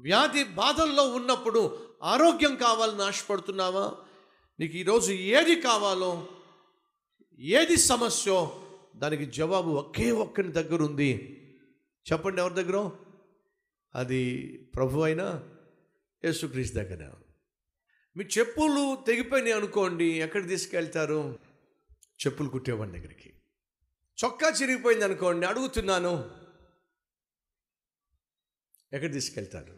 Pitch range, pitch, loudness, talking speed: 150-235 Hz, 190 Hz, -27 LUFS, 80 wpm